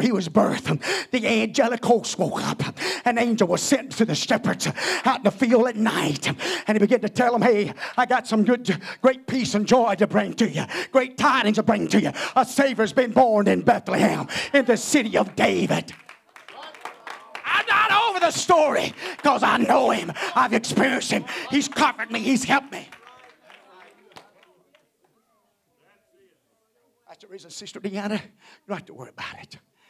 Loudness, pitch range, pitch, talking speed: -21 LUFS, 220-270 Hz, 240 Hz, 175 wpm